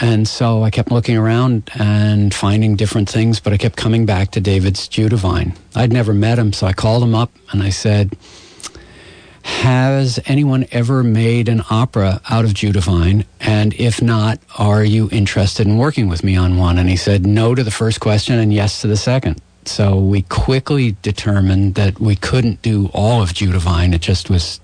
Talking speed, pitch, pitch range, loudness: 190 wpm, 105 Hz, 100-115 Hz, -15 LUFS